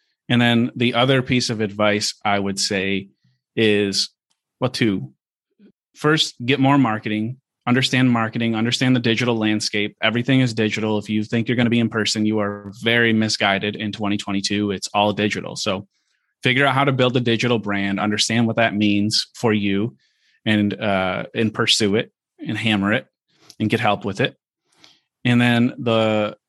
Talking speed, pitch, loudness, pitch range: 170 wpm, 110 Hz, -20 LUFS, 105-120 Hz